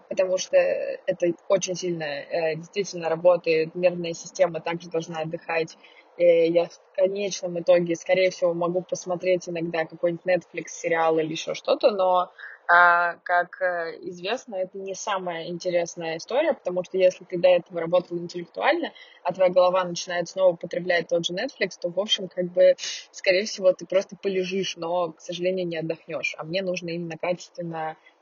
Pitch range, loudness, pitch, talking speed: 170-185 Hz, -25 LUFS, 180 Hz, 155 wpm